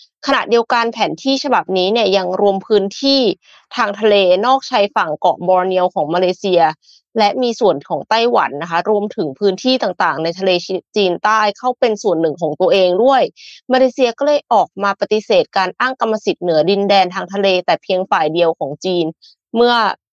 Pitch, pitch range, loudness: 200 Hz, 180-230 Hz, -15 LUFS